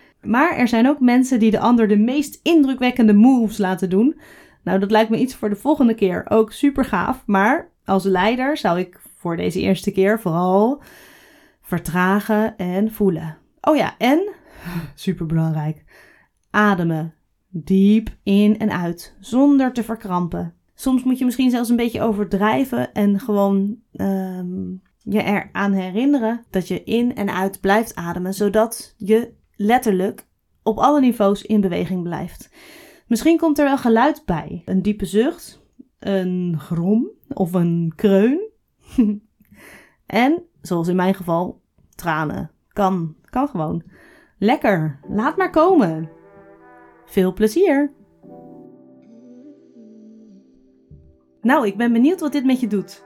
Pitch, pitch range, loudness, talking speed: 210 Hz, 185-250 Hz, -19 LUFS, 135 wpm